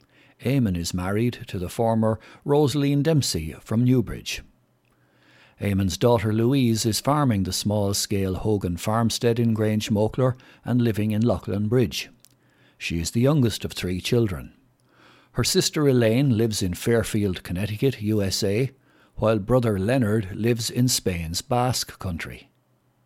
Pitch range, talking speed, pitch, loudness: 100-125 Hz, 130 wpm, 110 Hz, -23 LUFS